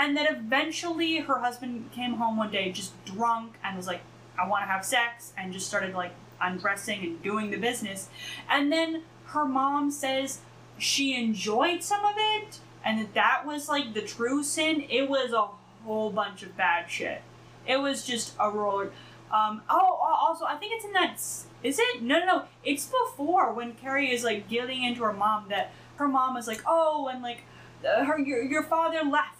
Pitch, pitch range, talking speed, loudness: 245 Hz, 215-295 Hz, 195 wpm, -28 LUFS